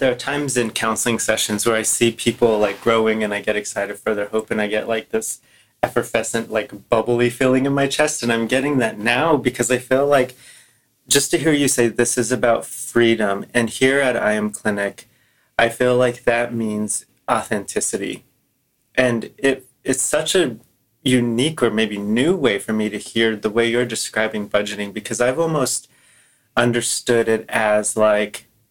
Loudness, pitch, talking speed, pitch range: -19 LUFS, 115 Hz, 180 wpm, 110-125 Hz